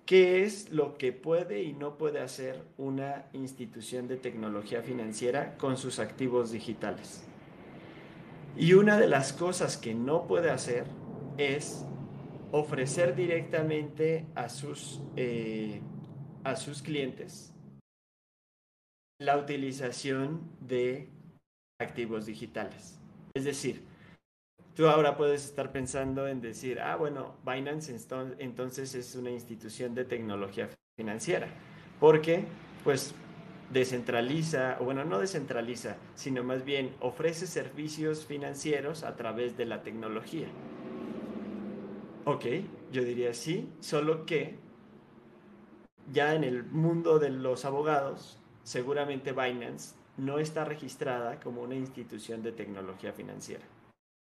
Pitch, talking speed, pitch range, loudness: 135 Hz, 110 wpm, 125-155 Hz, -32 LUFS